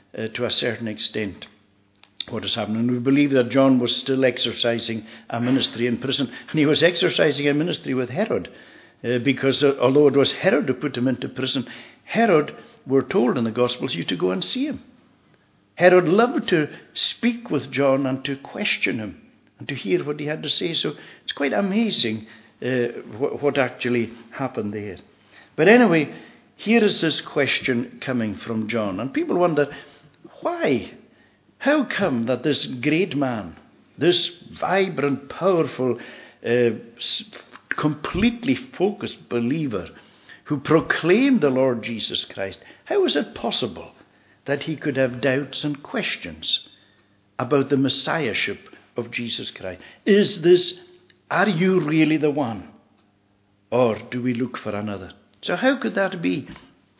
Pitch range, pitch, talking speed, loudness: 115-160 Hz, 135 Hz, 155 wpm, -22 LUFS